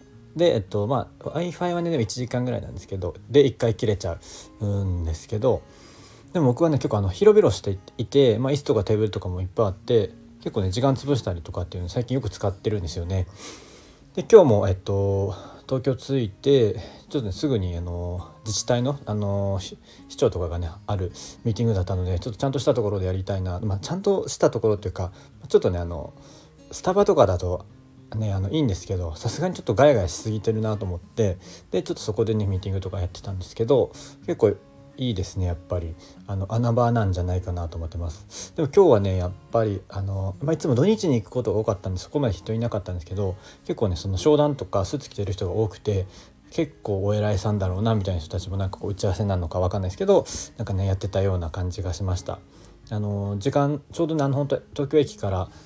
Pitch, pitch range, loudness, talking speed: 105 Hz, 95-120 Hz, -24 LUFS, 450 characters per minute